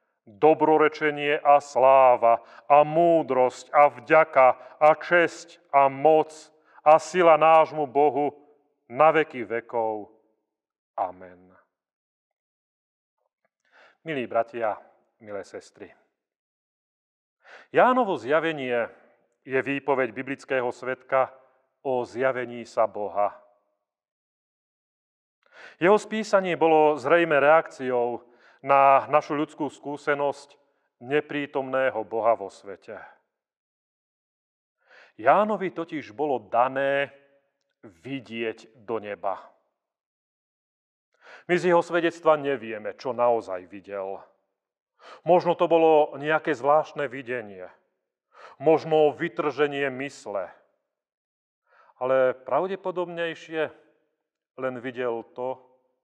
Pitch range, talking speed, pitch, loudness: 125-155 Hz, 80 wpm, 140 Hz, -23 LUFS